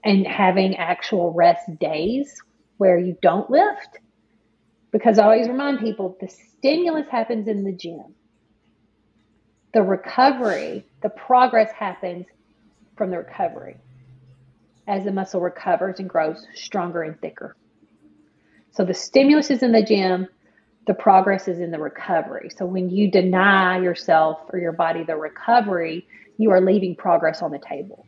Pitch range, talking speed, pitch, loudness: 170-220 Hz, 145 wpm, 190 Hz, -20 LUFS